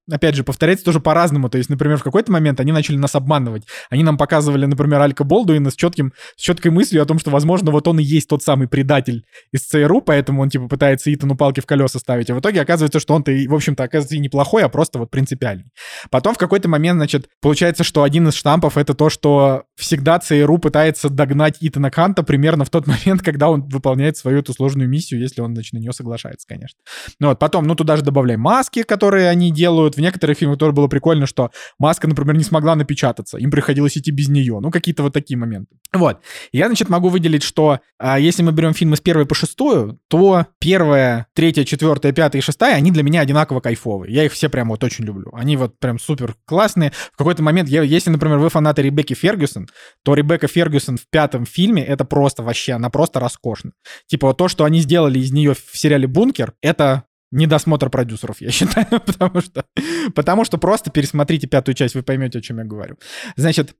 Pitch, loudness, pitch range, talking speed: 150 Hz, -16 LUFS, 135-160 Hz, 210 wpm